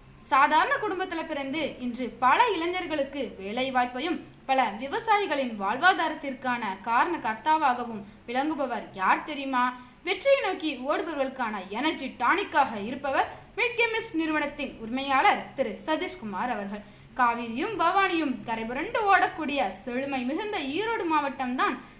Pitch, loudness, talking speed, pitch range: 275 Hz, -27 LUFS, 100 wpm, 250-330 Hz